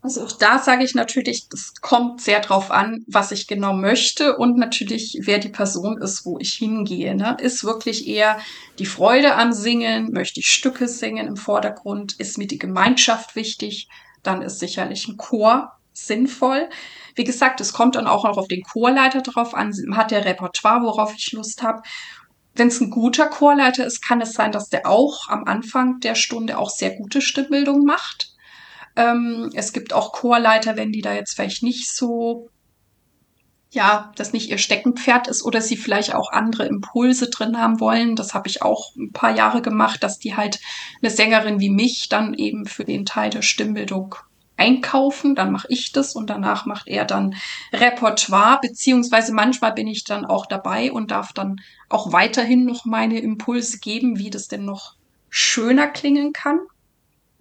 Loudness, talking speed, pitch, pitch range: -19 LUFS, 180 wpm, 230 Hz, 210-250 Hz